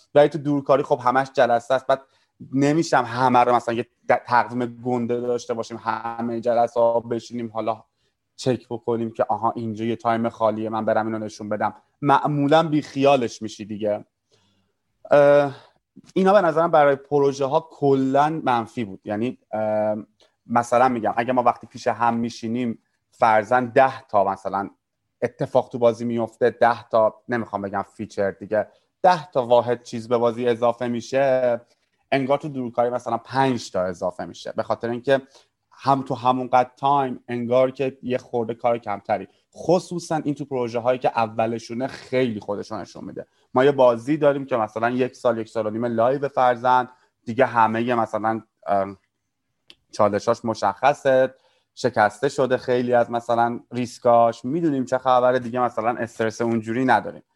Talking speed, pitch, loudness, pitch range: 155 wpm, 120 Hz, -22 LUFS, 115-130 Hz